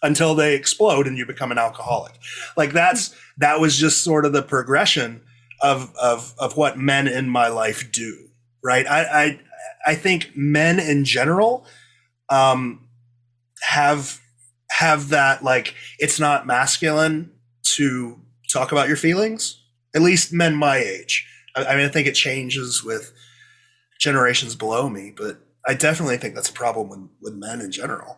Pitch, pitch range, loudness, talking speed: 135 Hz, 120-155 Hz, -19 LUFS, 160 wpm